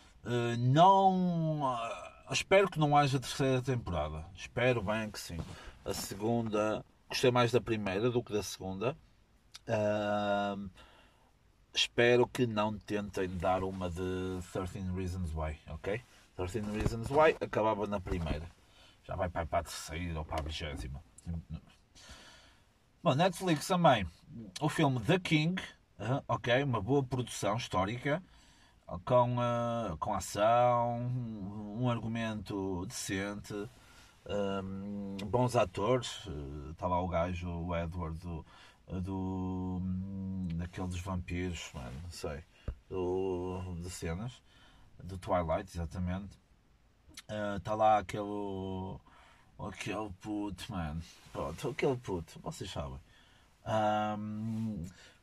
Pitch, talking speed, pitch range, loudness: 100 Hz, 115 wpm, 90-120 Hz, -34 LUFS